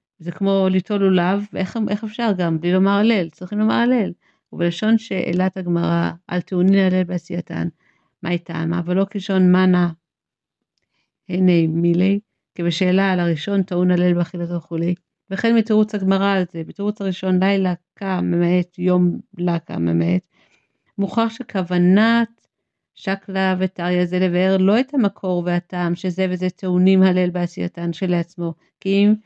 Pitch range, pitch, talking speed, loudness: 175-195 Hz, 185 Hz, 135 wpm, -19 LUFS